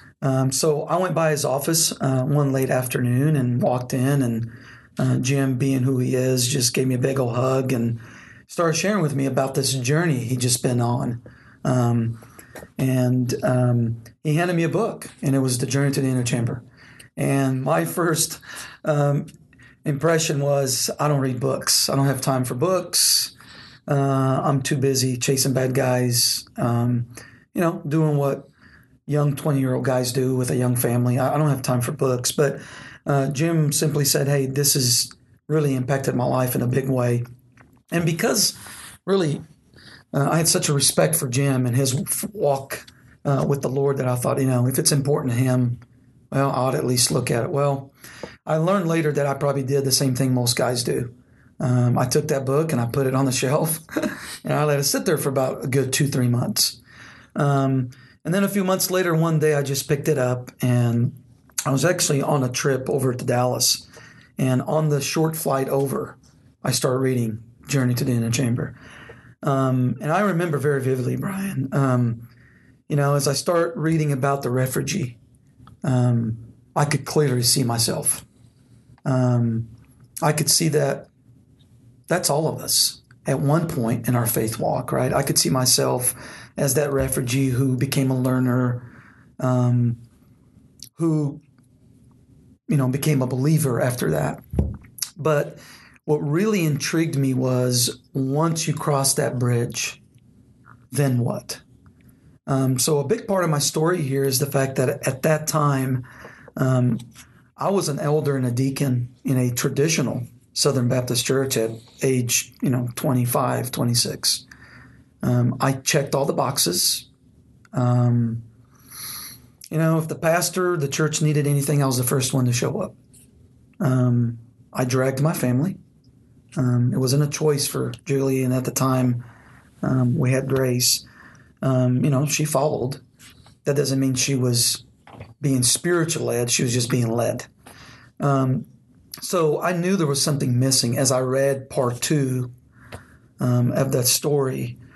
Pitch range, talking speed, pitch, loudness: 125-145 Hz, 175 wpm, 130 Hz, -21 LUFS